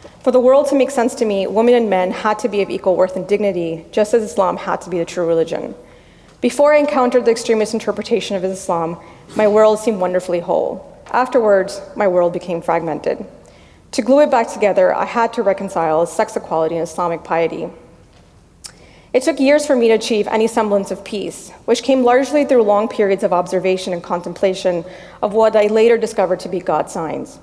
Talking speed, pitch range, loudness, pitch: 195 wpm, 180-230 Hz, -16 LUFS, 205 Hz